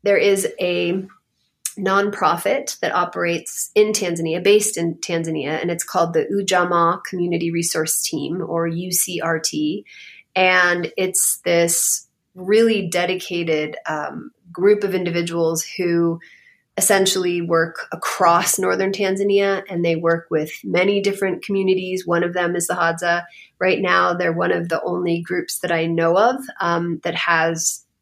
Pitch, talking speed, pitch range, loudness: 175 Hz, 135 wpm, 170-190 Hz, -19 LUFS